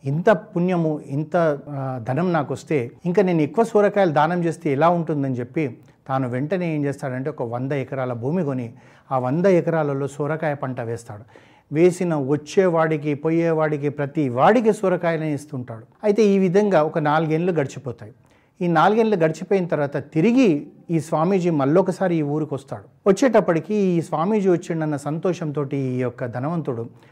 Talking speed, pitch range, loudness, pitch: 135 wpm, 140-175 Hz, -21 LUFS, 155 Hz